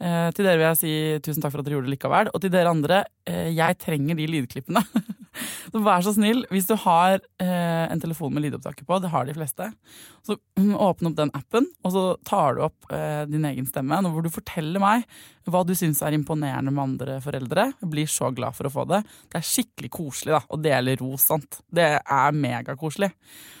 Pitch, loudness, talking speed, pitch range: 165 Hz, -24 LUFS, 210 wpm, 150-190 Hz